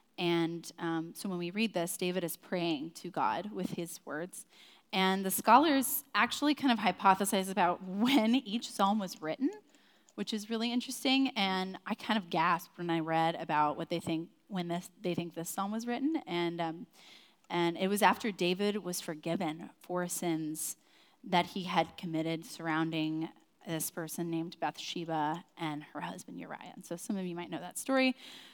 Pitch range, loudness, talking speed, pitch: 170-220 Hz, -33 LUFS, 180 wpm, 180 Hz